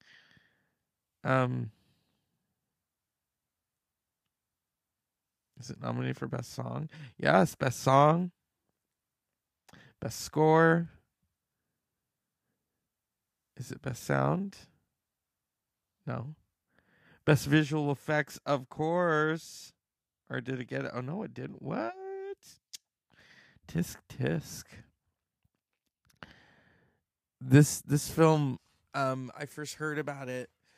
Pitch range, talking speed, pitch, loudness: 130-155 Hz, 85 wpm, 145 Hz, -30 LUFS